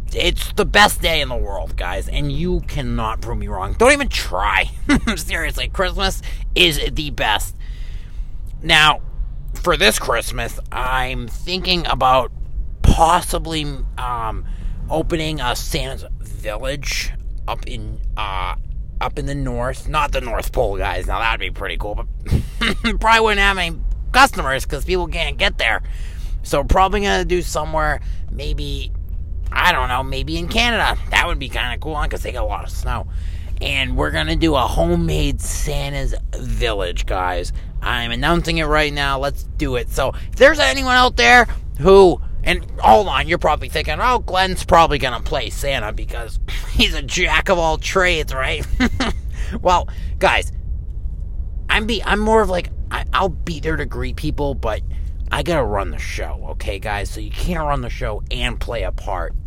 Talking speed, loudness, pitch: 170 wpm, -18 LUFS, 120 Hz